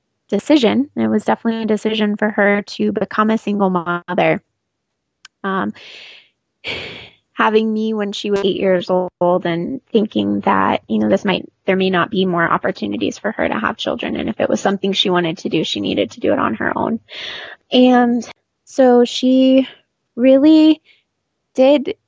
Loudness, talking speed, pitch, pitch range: -16 LUFS, 170 wpm, 210 Hz, 185-245 Hz